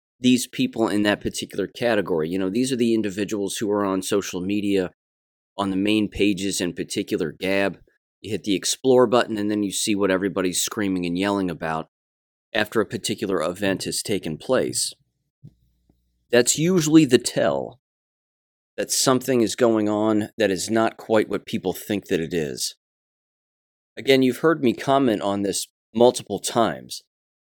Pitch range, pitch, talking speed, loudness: 95-115 Hz, 100 Hz, 160 wpm, -22 LUFS